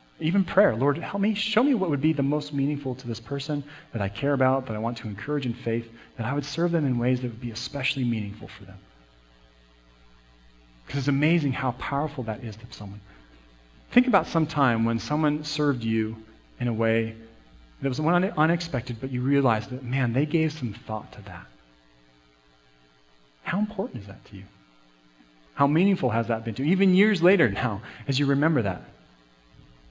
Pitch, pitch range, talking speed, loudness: 120 Hz, 95-145 Hz, 195 wpm, -25 LUFS